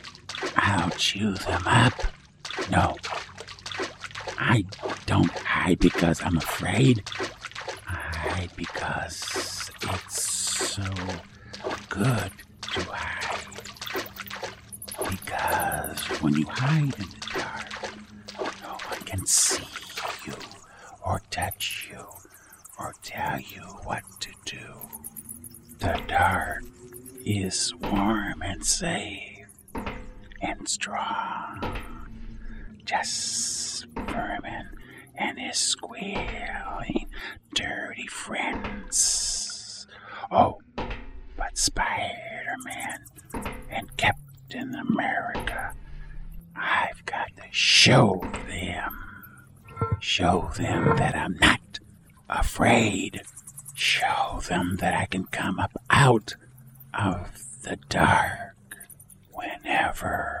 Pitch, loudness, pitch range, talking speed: 105 Hz, -26 LUFS, 95-120 Hz, 80 wpm